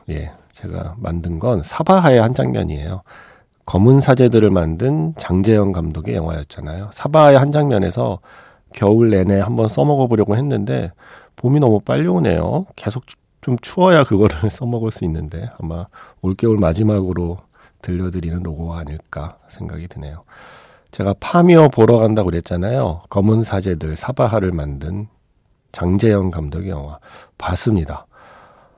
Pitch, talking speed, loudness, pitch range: 100 Hz, 315 characters per minute, -16 LUFS, 85-120 Hz